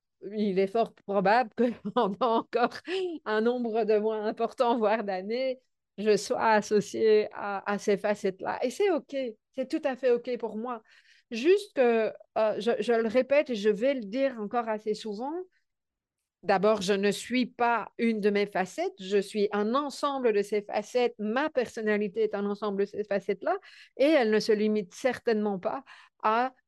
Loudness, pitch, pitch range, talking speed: -28 LUFS, 225 Hz, 210-250 Hz, 175 wpm